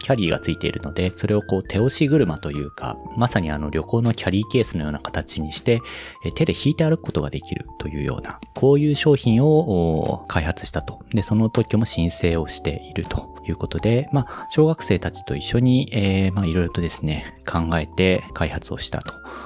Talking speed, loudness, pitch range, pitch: 390 characters per minute, -22 LUFS, 80-120 Hz, 100 Hz